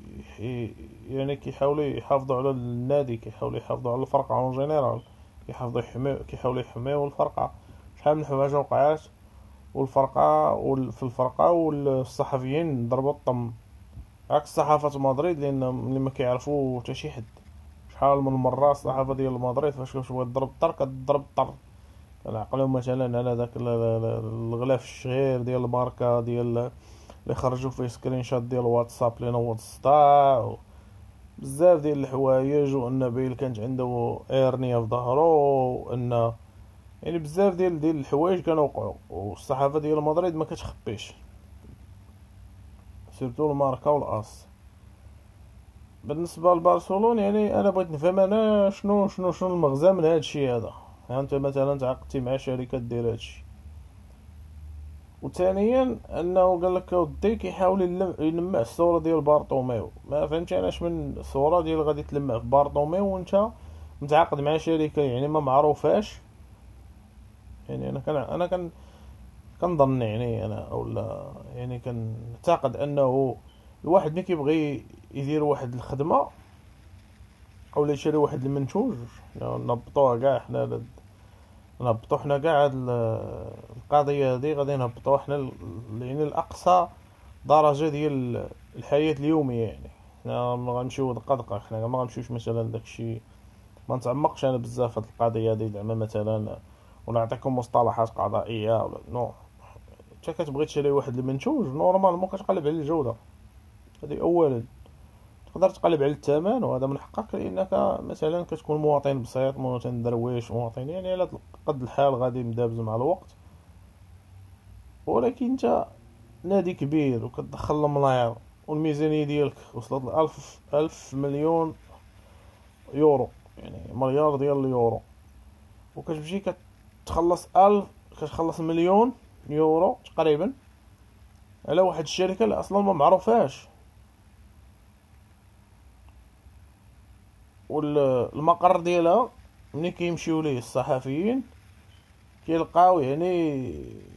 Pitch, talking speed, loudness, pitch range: 130 Hz, 115 wpm, -25 LUFS, 110-150 Hz